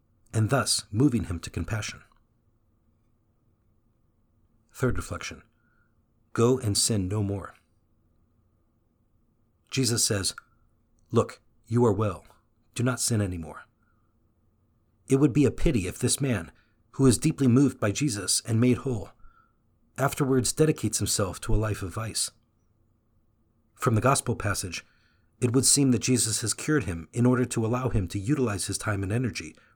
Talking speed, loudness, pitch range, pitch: 145 wpm, -26 LUFS, 100-120 Hz, 110 Hz